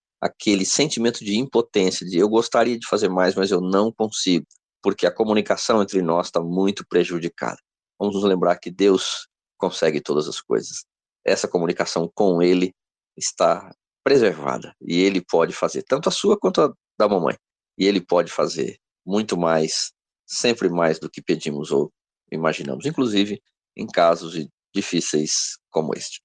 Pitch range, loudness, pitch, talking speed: 85-100 Hz, -21 LUFS, 95 Hz, 155 wpm